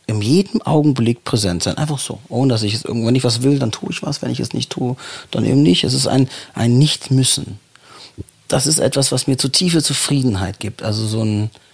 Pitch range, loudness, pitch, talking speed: 110-140 Hz, -17 LUFS, 125 Hz, 225 wpm